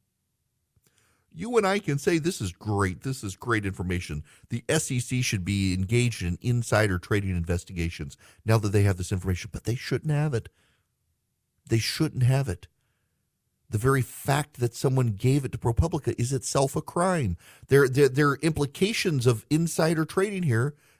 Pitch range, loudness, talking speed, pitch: 100-145 Hz, -26 LUFS, 165 wpm, 120 Hz